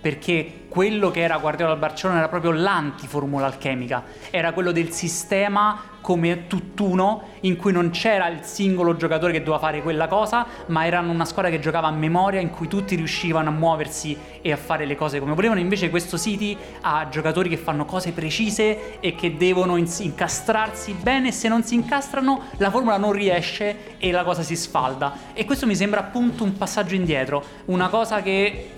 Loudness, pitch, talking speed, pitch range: -22 LUFS, 175 Hz, 185 wpm, 160-205 Hz